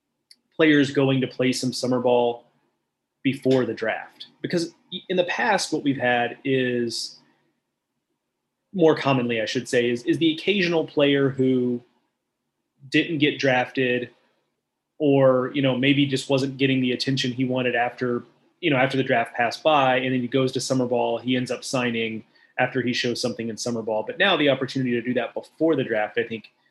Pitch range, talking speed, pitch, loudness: 120-140 Hz, 180 wpm, 130 Hz, -23 LUFS